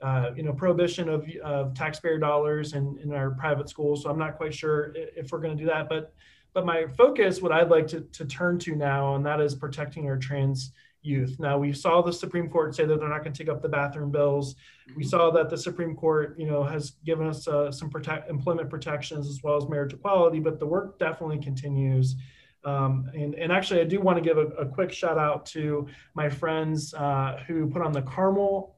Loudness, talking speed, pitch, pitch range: -27 LUFS, 225 wpm, 155 Hz, 145-165 Hz